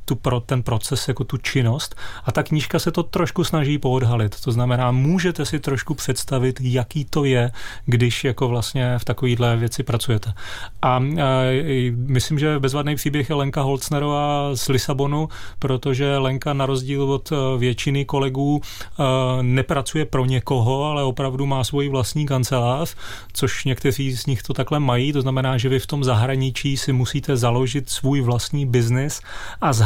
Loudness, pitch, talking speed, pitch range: -21 LUFS, 135 Hz, 160 wpm, 125-145 Hz